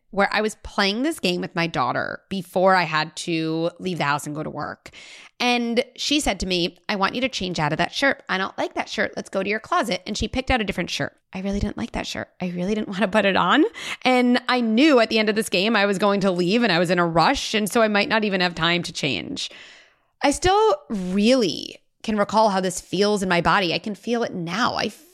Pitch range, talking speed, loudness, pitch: 180-240 Hz, 265 wpm, -22 LUFS, 205 Hz